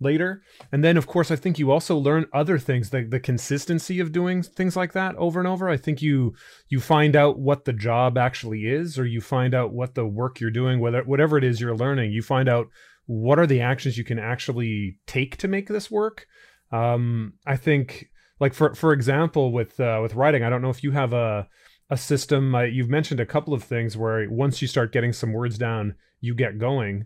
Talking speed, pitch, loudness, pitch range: 225 wpm, 135 Hz, -23 LUFS, 120-150 Hz